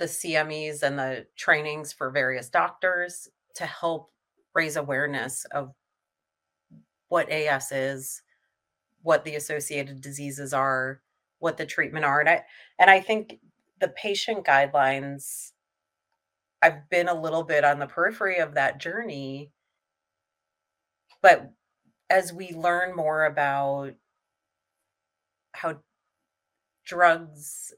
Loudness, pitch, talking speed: -25 LUFS, 140 Hz, 110 wpm